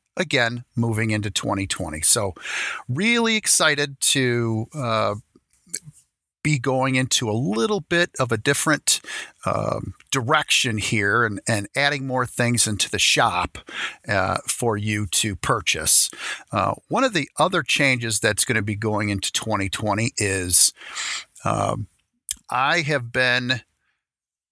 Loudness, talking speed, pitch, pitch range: -21 LUFS, 125 wpm, 120 Hz, 105-140 Hz